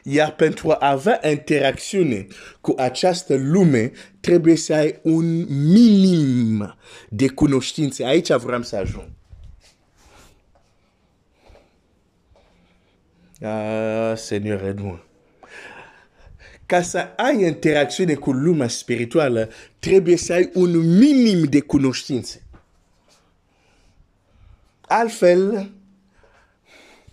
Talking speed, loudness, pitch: 90 wpm, -19 LUFS, 130 Hz